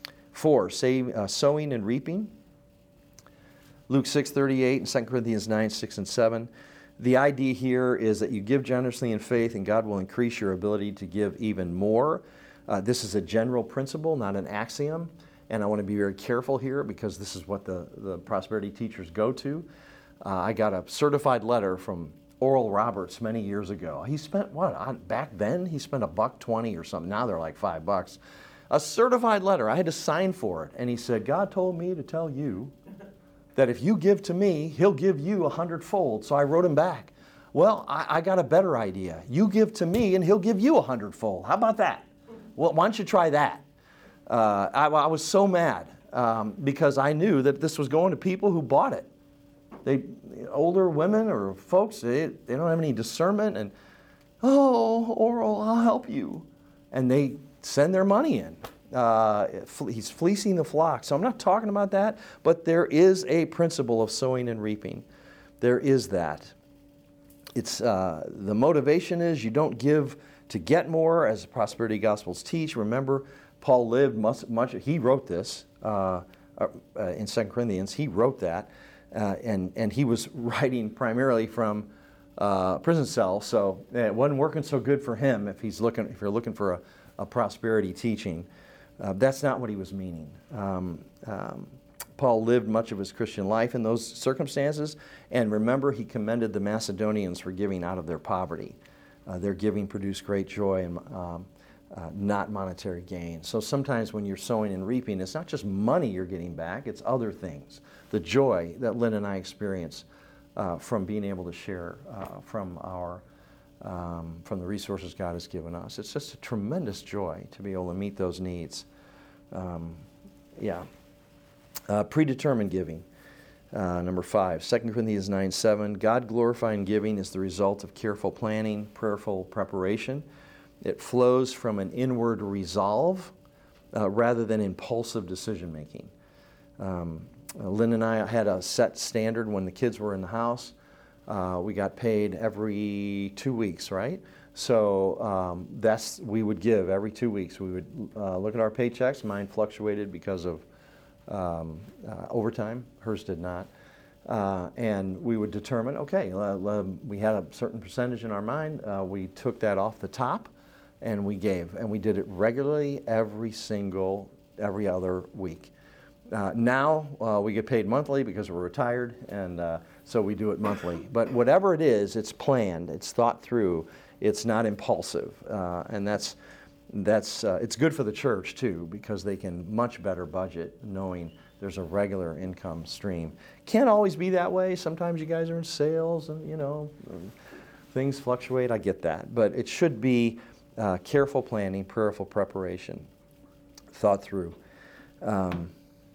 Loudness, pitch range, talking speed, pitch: -27 LUFS, 100-140 Hz, 175 wpm, 110 Hz